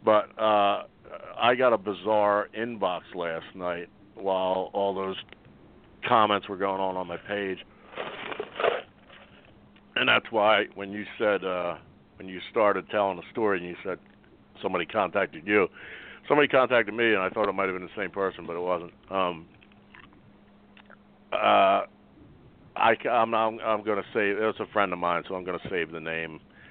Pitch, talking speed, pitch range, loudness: 95 Hz, 170 wpm, 90-105 Hz, -27 LUFS